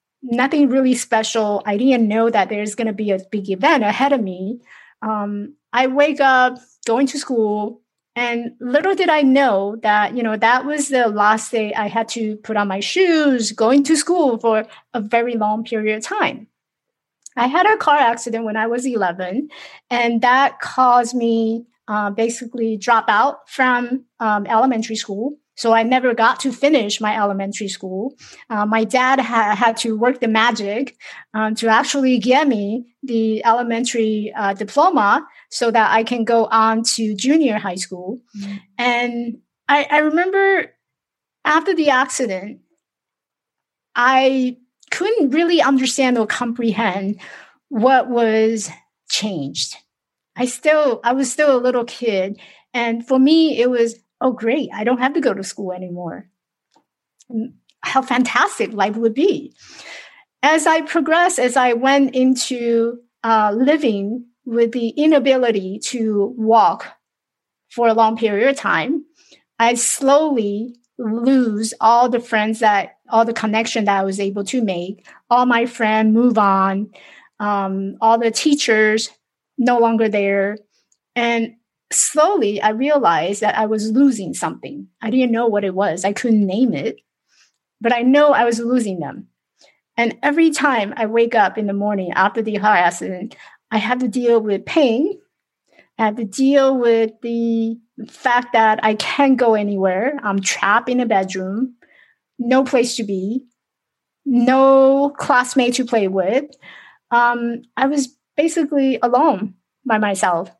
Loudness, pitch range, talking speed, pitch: -17 LUFS, 215-260 Hz, 150 wpm, 235 Hz